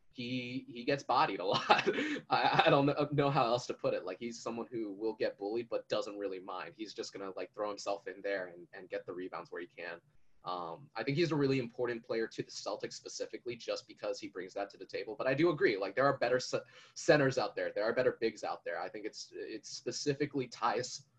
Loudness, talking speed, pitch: -35 LUFS, 250 wpm, 145 Hz